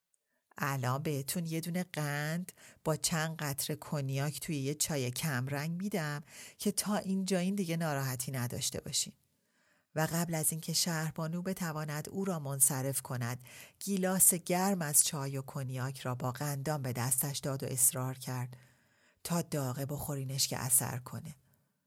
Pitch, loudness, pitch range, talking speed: 145 Hz, -33 LUFS, 130-165 Hz, 150 wpm